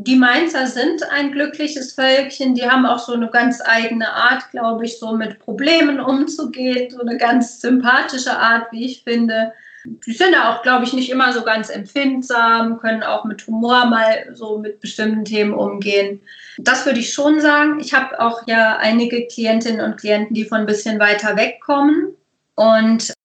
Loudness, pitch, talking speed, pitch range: -16 LUFS, 240 Hz, 180 wpm, 225-265 Hz